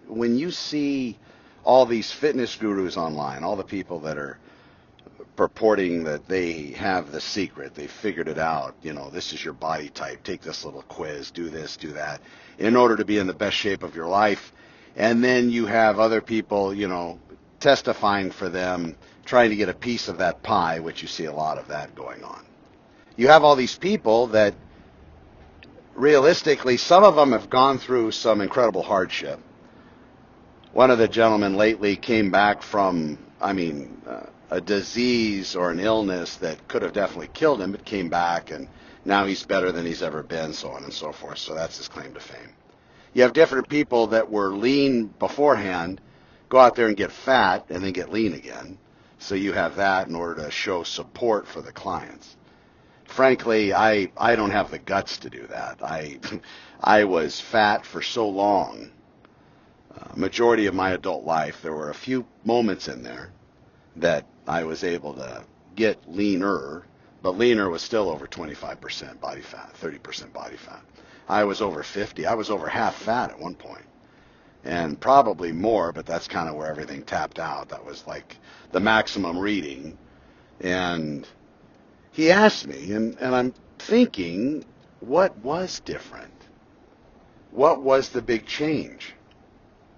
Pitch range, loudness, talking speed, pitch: 85-120 Hz, -23 LUFS, 175 wpm, 105 Hz